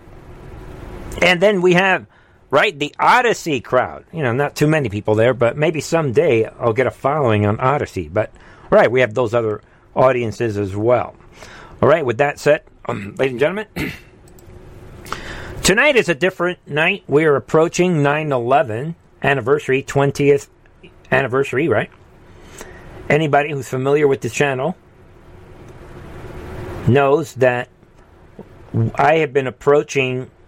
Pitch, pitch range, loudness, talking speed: 135 Hz, 120-150 Hz, -17 LUFS, 135 wpm